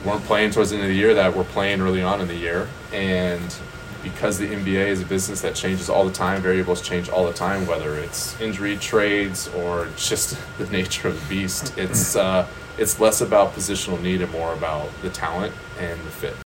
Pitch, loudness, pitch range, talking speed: 95 Hz, -22 LUFS, 90-100 Hz, 215 wpm